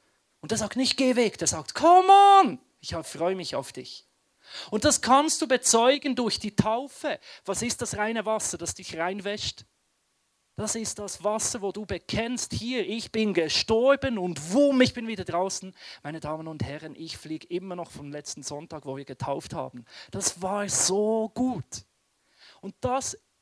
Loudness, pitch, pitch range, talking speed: -25 LUFS, 205 Hz, 165-240 Hz, 175 wpm